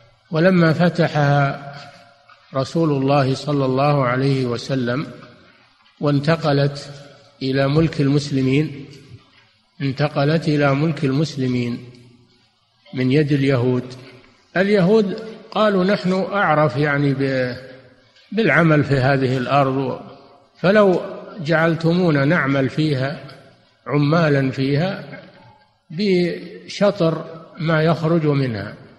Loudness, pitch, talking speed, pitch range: -18 LUFS, 140 Hz, 80 wpm, 135-165 Hz